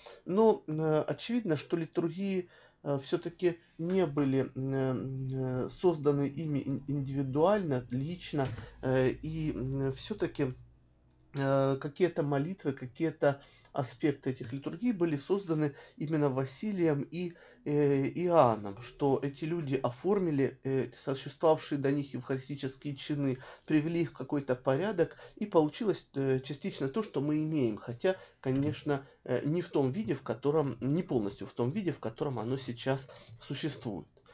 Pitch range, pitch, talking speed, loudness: 130-160 Hz, 140 Hz, 125 wpm, -33 LUFS